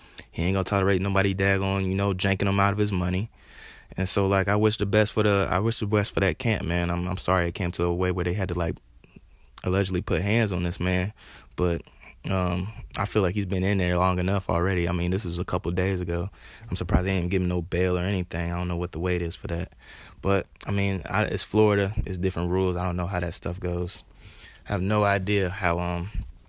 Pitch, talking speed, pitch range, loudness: 95 Hz, 250 wpm, 90-100 Hz, -26 LUFS